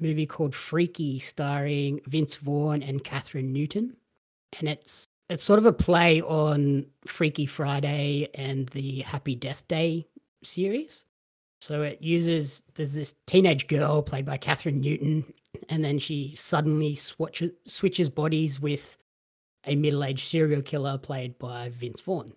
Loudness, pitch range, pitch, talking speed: -27 LUFS, 140-160 Hz, 150 Hz, 140 wpm